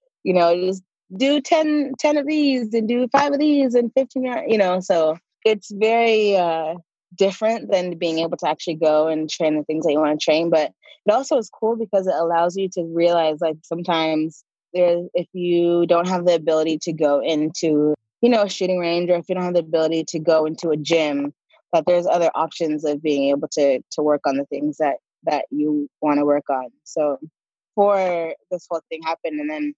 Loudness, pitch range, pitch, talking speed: -20 LUFS, 155-195 Hz, 170 Hz, 210 wpm